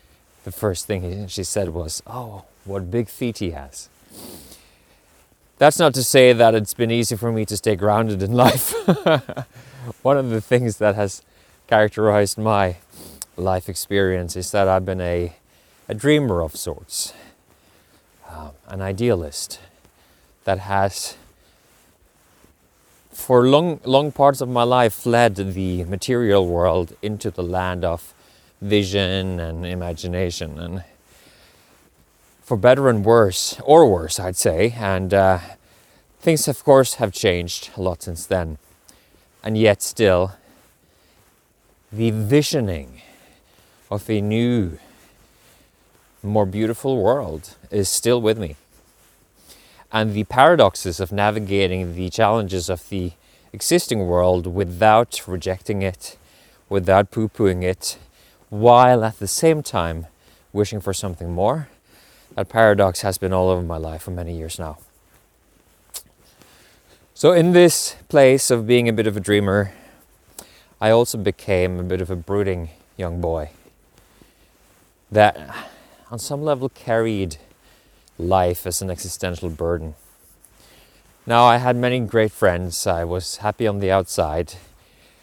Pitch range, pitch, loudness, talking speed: 90-115 Hz, 100 Hz, -19 LUFS, 130 wpm